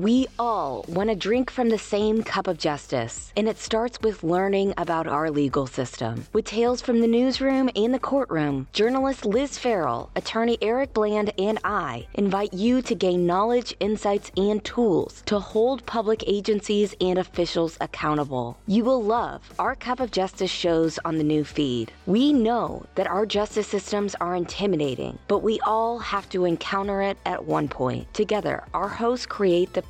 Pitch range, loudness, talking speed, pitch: 180-230 Hz, -24 LUFS, 175 wpm, 205 Hz